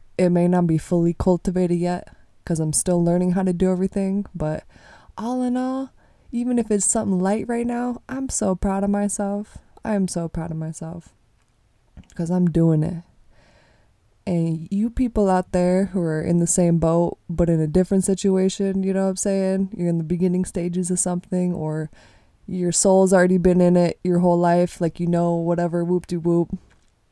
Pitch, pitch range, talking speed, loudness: 180 Hz, 170-195 Hz, 190 wpm, -21 LUFS